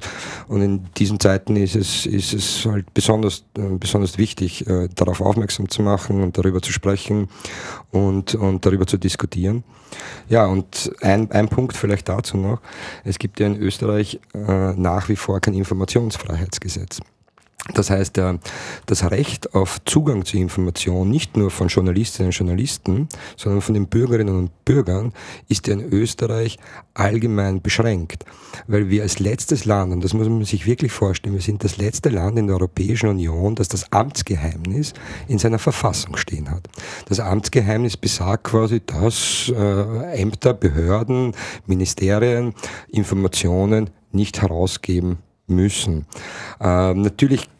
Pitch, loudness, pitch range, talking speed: 100 Hz, -20 LUFS, 95-110 Hz, 140 wpm